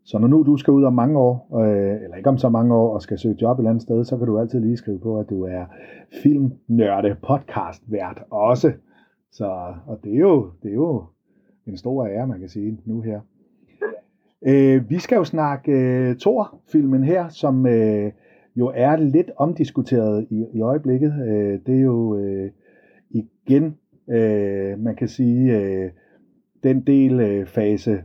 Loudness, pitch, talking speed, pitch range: -20 LUFS, 120 Hz, 185 wpm, 105-135 Hz